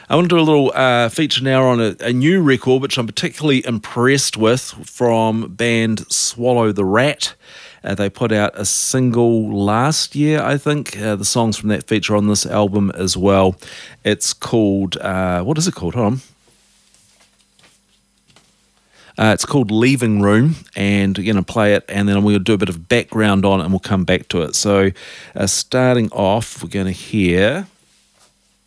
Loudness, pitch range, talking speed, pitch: -16 LUFS, 100-130 Hz, 185 wpm, 110 Hz